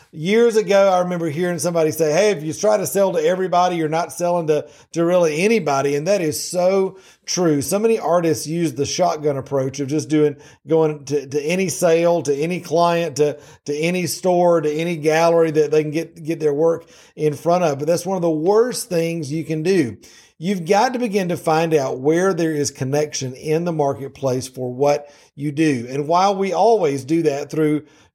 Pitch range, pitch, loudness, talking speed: 150-175 Hz, 165 Hz, -19 LUFS, 205 wpm